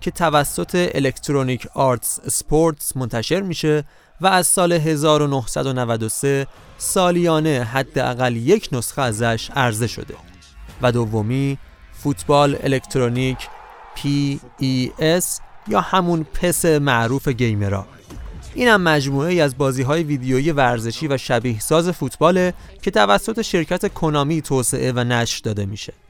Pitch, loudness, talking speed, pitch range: 140 Hz, -19 LUFS, 115 wpm, 125-160 Hz